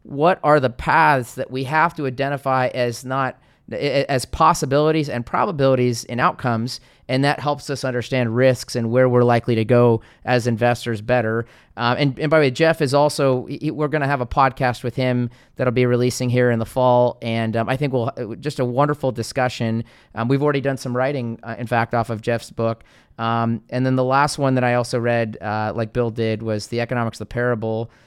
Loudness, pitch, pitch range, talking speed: -20 LUFS, 125 Hz, 115-135 Hz, 210 wpm